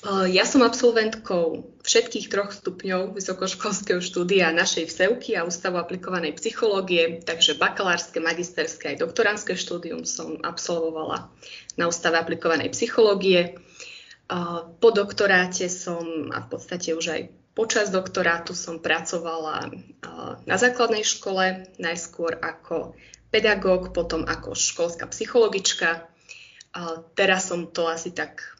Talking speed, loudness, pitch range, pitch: 110 wpm, -23 LUFS, 165-200 Hz, 180 Hz